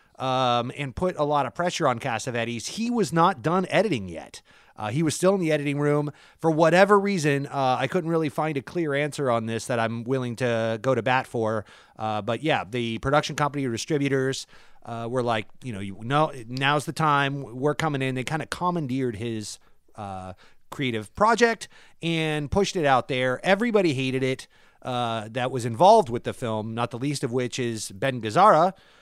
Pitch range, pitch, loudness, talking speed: 120-155 Hz, 135 Hz, -24 LUFS, 195 wpm